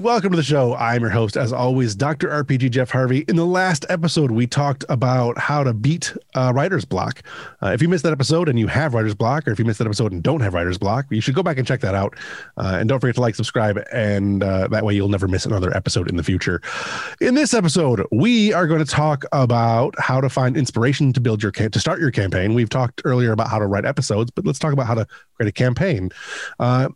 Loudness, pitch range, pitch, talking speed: -19 LUFS, 110-145 Hz, 125 Hz, 255 wpm